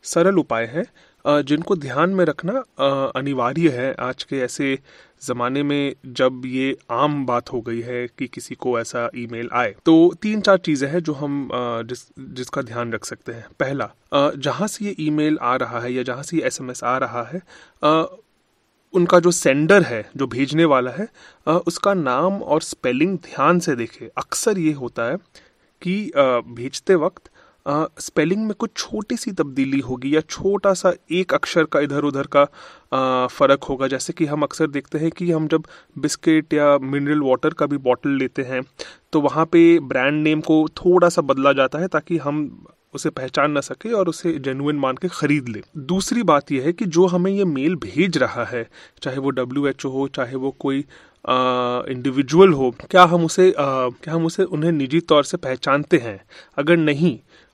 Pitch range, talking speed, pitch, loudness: 130-175 Hz, 185 wpm, 150 Hz, -20 LUFS